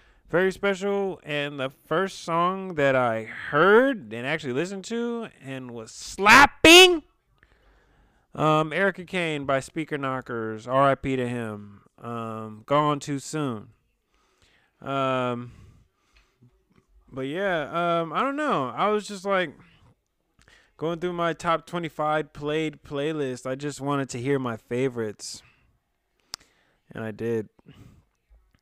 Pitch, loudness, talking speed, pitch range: 145 Hz, -23 LUFS, 120 wpm, 125-175 Hz